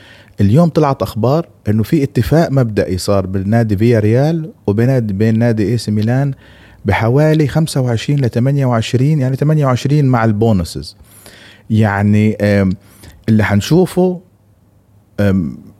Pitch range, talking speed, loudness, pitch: 100-135 Hz, 110 wpm, -14 LUFS, 115 Hz